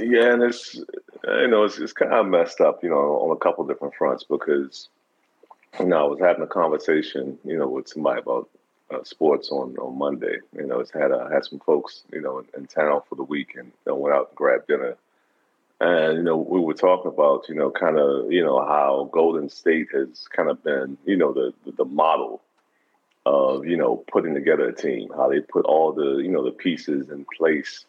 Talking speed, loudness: 210 wpm, -22 LUFS